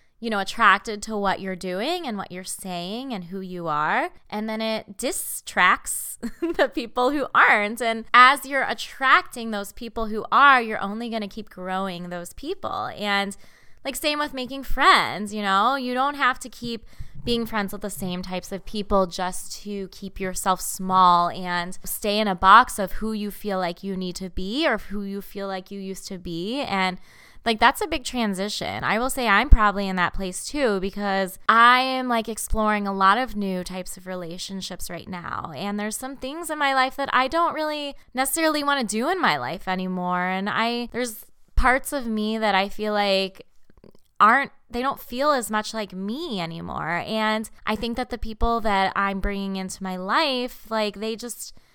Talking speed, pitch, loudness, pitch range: 195 wpm, 210 Hz, -23 LUFS, 190-250 Hz